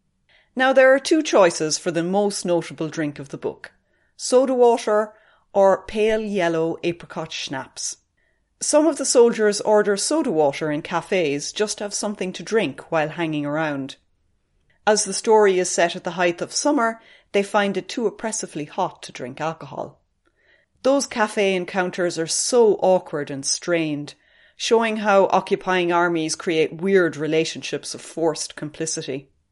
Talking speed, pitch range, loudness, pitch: 150 wpm, 160-215 Hz, -21 LUFS, 180 Hz